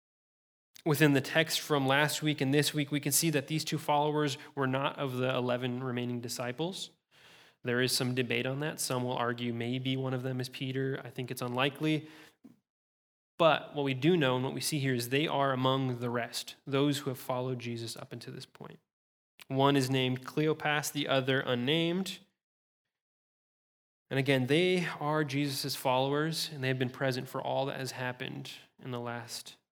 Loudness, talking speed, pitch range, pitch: -31 LUFS, 190 wpm, 125-150 Hz, 135 Hz